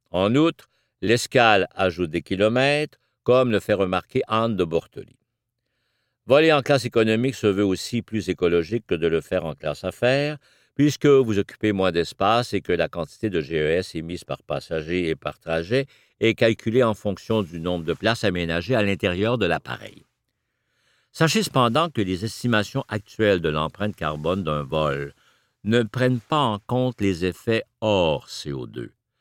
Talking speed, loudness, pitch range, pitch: 160 wpm, -23 LUFS, 90-125 Hz, 110 Hz